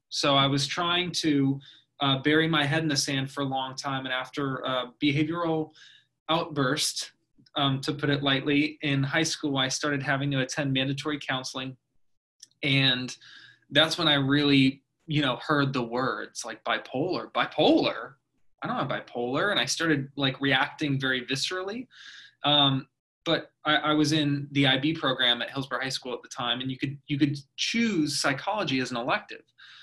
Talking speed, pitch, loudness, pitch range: 175 wpm, 140 Hz, -26 LUFS, 135-150 Hz